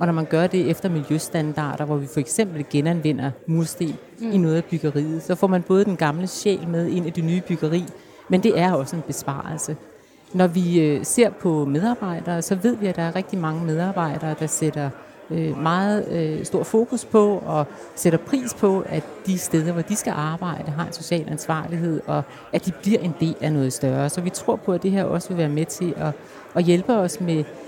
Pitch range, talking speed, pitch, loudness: 155-185 Hz, 210 wpm, 170 Hz, -22 LUFS